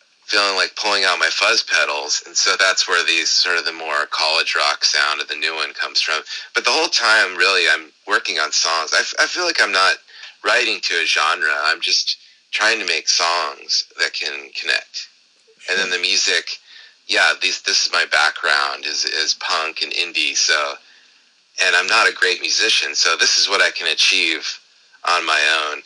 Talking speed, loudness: 200 wpm, -16 LUFS